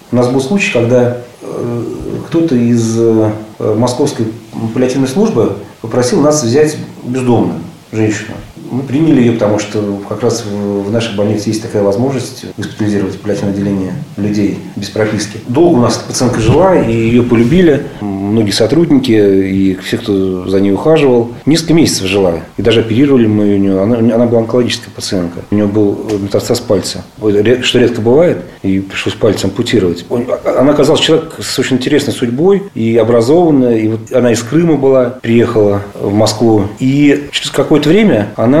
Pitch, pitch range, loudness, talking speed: 115 Hz, 105-125 Hz, -11 LUFS, 155 wpm